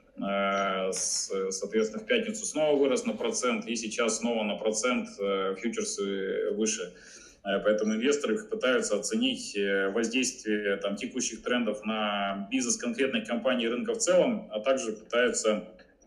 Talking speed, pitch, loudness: 120 wpm, 115 Hz, -29 LUFS